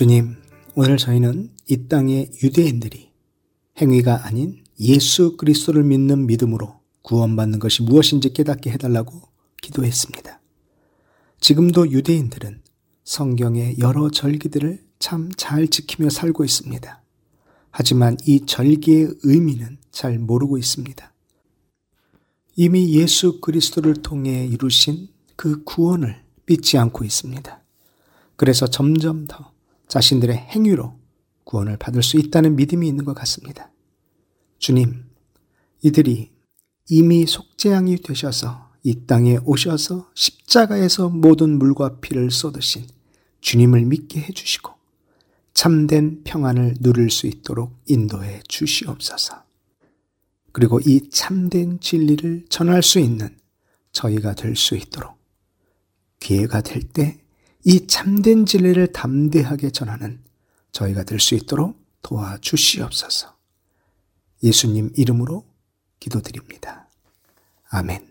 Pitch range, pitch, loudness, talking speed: 120-155 Hz, 135 Hz, -17 LUFS, 255 characters per minute